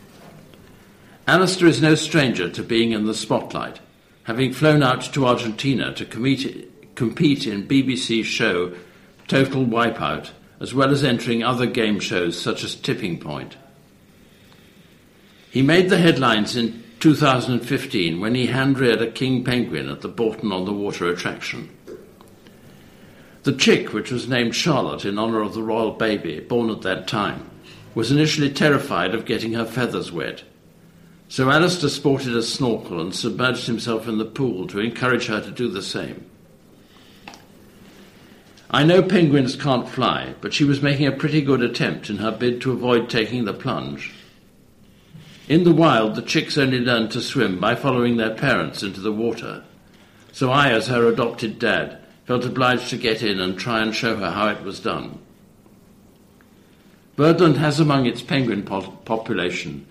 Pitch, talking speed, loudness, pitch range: 120 Hz, 155 wpm, -20 LUFS, 110-135 Hz